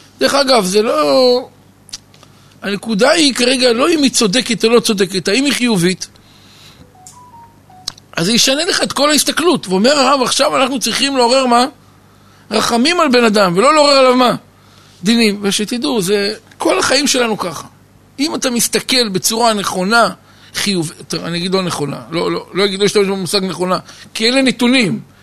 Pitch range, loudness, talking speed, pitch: 195-265 Hz, -13 LUFS, 160 wpm, 230 Hz